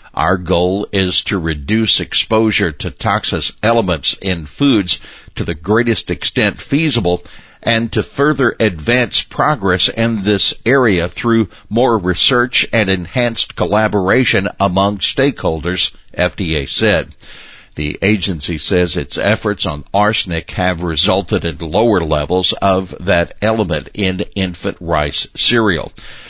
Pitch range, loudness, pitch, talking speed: 90-110 Hz, -14 LUFS, 100 Hz, 120 wpm